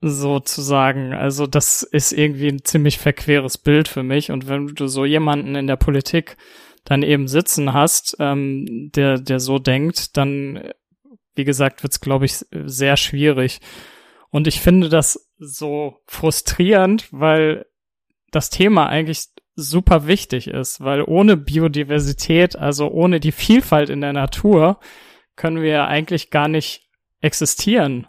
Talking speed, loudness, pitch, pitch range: 140 wpm, -17 LUFS, 150 Hz, 140-160 Hz